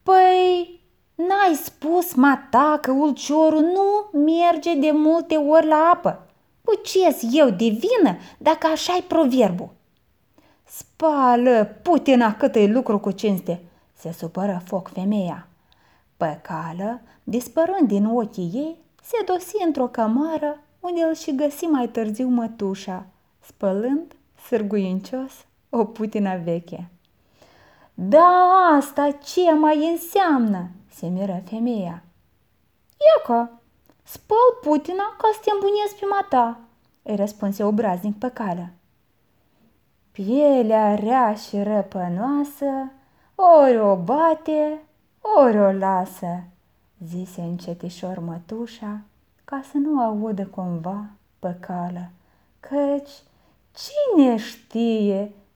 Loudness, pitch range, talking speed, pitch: -20 LUFS, 200-310 Hz, 105 wpm, 245 Hz